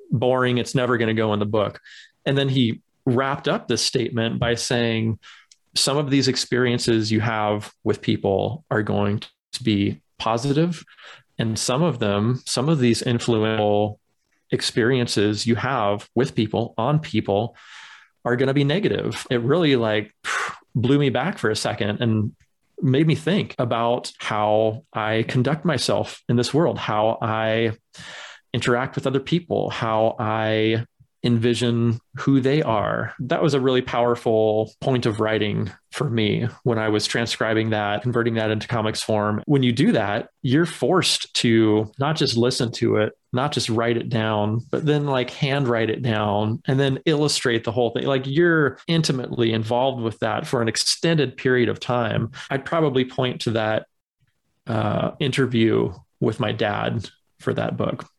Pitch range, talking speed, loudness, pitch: 110-135 Hz, 165 wpm, -22 LUFS, 120 Hz